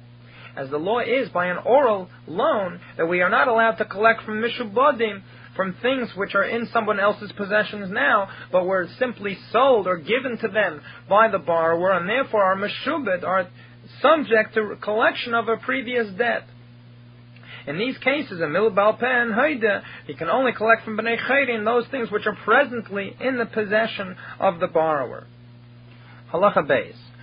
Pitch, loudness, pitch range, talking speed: 210 Hz, -21 LUFS, 175-235 Hz, 165 wpm